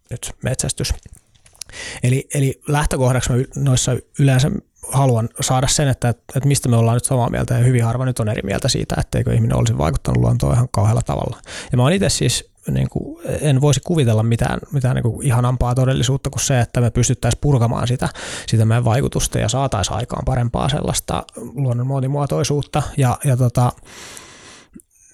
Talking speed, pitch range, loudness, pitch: 165 wpm, 115-135 Hz, -18 LUFS, 125 Hz